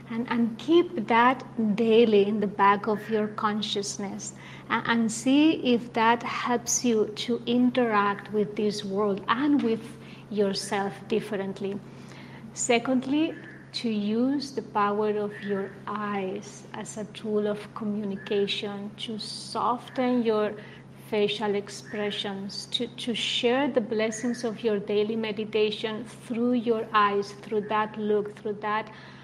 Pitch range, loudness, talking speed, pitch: 205-235 Hz, -27 LUFS, 125 wpm, 215 Hz